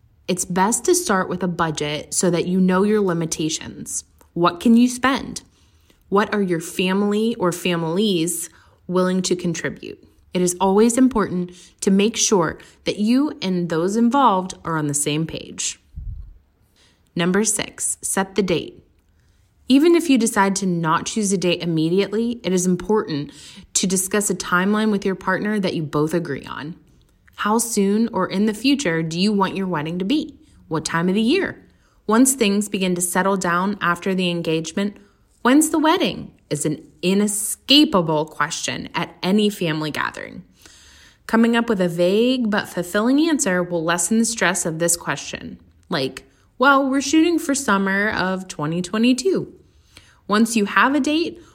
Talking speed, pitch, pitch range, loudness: 160 wpm, 185 Hz, 170-215 Hz, -20 LUFS